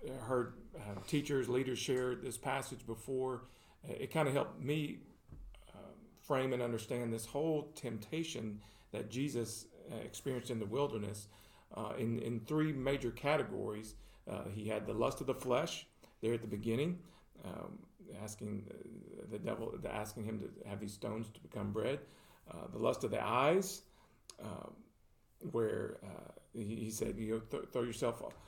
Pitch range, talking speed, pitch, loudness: 110-135 Hz, 165 wpm, 120 Hz, -40 LUFS